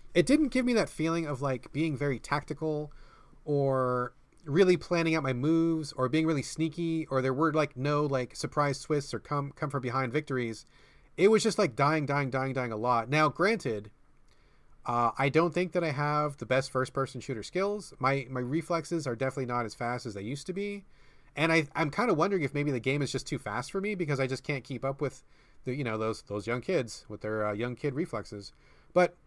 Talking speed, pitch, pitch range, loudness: 225 wpm, 145 Hz, 130-160 Hz, -30 LUFS